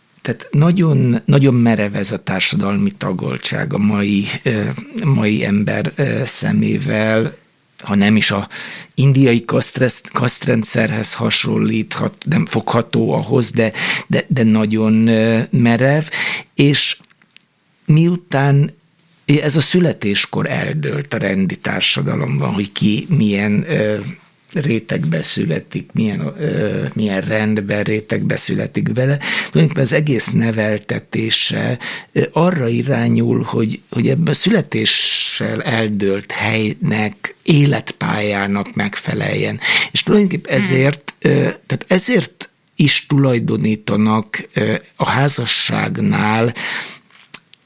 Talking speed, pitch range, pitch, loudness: 95 wpm, 110-155 Hz, 120 Hz, -15 LUFS